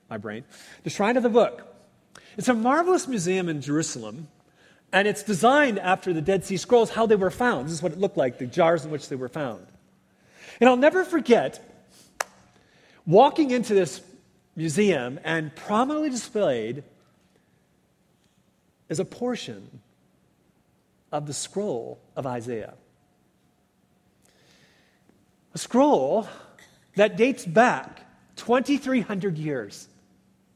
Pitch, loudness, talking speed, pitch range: 200 Hz, -24 LUFS, 125 wpm, 160-245 Hz